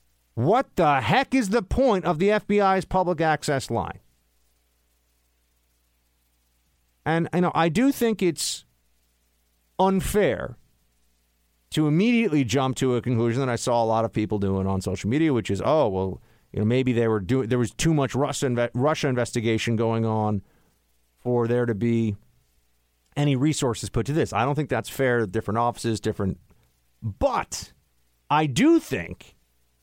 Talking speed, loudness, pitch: 160 wpm, -24 LUFS, 115 Hz